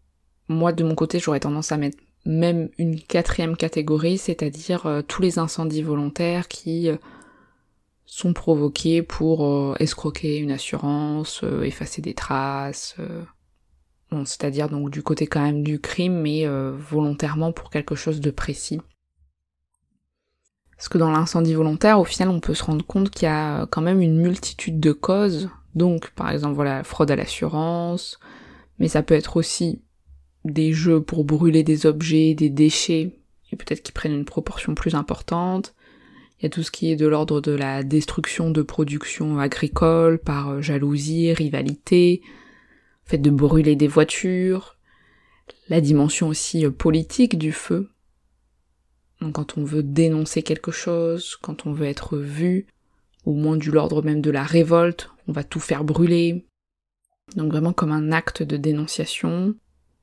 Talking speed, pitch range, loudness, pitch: 155 wpm, 150-170 Hz, -22 LUFS, 155 Hz